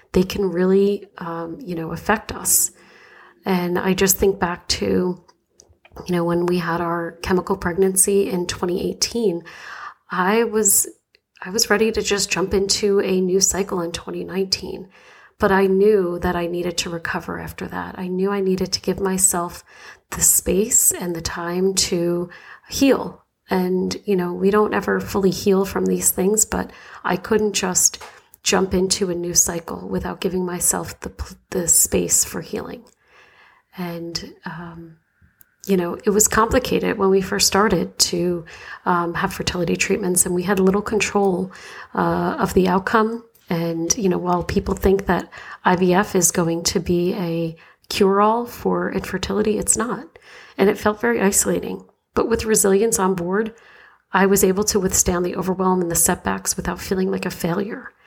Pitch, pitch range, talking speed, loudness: 190 Hz, 175-200 Hz, 165 wpm, -19 LUFS